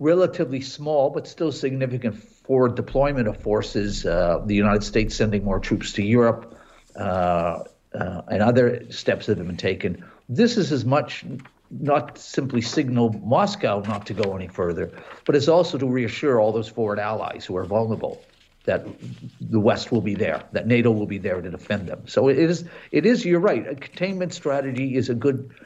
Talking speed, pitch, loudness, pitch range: 185 wpm, 120 Hz, -23 LUFS, 105-140 Hz